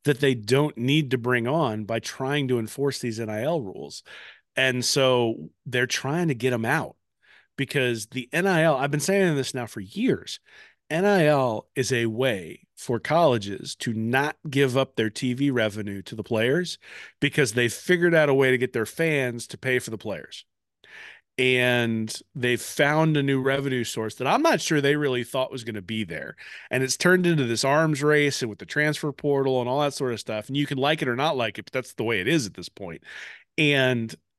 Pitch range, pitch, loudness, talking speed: 120-145 Hz, 130 Hz, -24 LUFS, 210 wpm